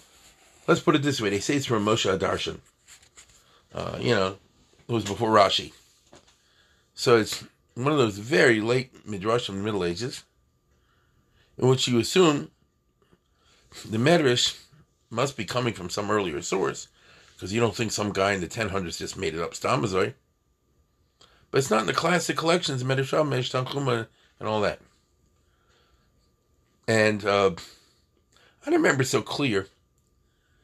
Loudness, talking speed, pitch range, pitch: -25 LUFS, 150 wpm, 100-130 Hz, 110 Hz